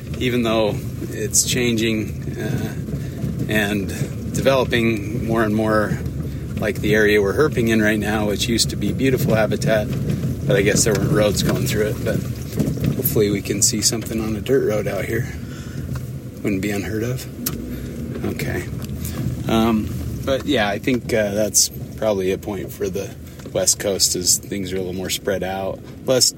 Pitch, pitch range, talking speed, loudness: 110 Hz, 105-120 Hz, 165 wpm, -20 LUFS